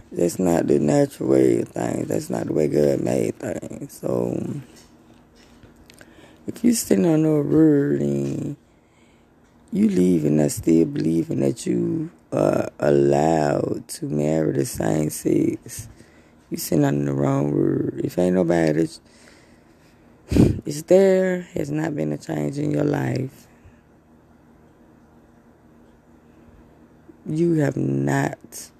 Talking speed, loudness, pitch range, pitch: 125 wpm, -21 LUFS, 75-115 Hz, 80 Hz